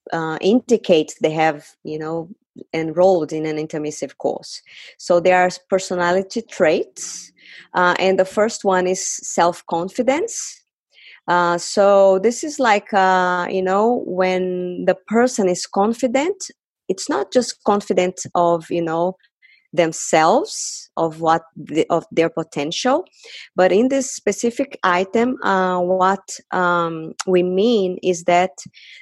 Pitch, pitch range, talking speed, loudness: 185 Hz, 175-220 Hz, 130 wpm, -19 LUFS